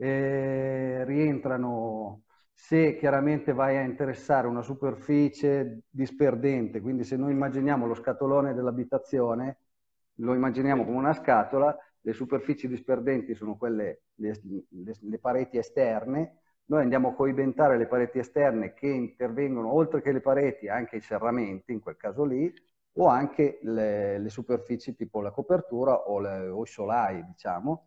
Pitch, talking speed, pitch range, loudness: 130 Hz, 140 wpm, 115-140 Hz, -28 LUFS